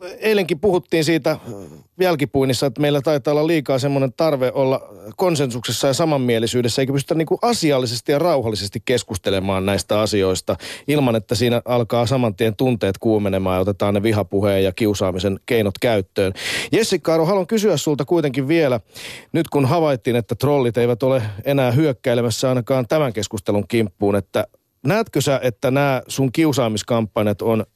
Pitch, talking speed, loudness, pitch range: 130 Hz, 145 wpm, -19 LUFS, 110-150 Hz